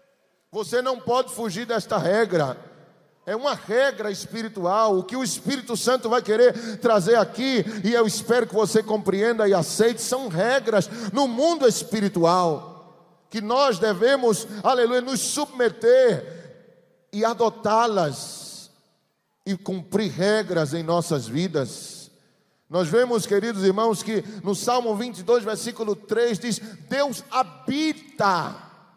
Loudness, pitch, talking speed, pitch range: -23 LUFS, 220 Hz, 120 wpm, 190-240 Hz